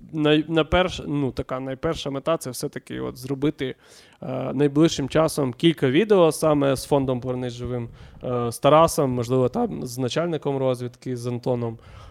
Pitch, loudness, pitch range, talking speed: 135 Hz, -23 LUFS, 125-155 Hz, 145 wpm